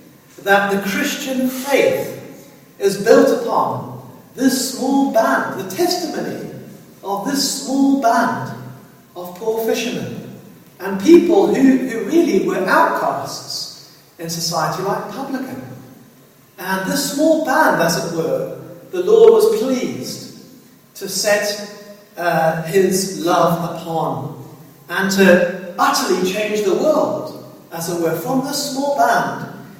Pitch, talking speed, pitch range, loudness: 210 Hz, 120 wpm, 180-275 Hz, -17 LUFS